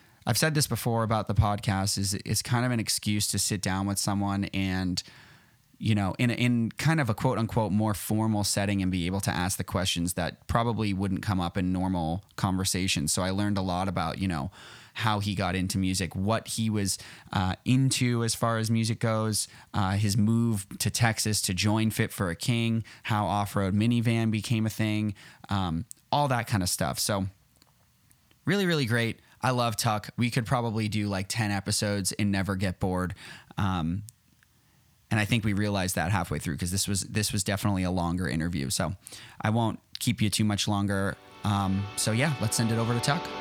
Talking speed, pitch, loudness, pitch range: 200 wpm, 105 Hz, -28 LUFS, 95-115 Hz